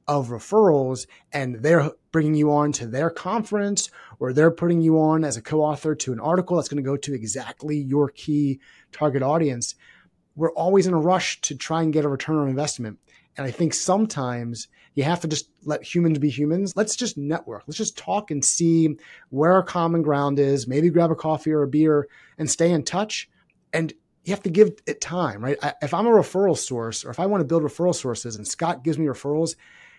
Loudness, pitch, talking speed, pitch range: -23 LUFS, 155 Hz, 215 wpm, 140-170 Hz